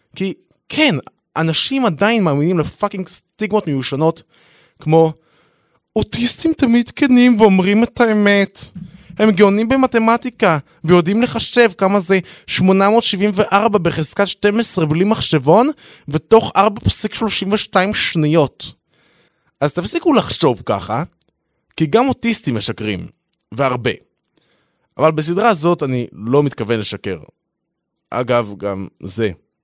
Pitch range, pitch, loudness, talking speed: 155-220 Hz, 190 Hz, -15 LUFS, 105 wpm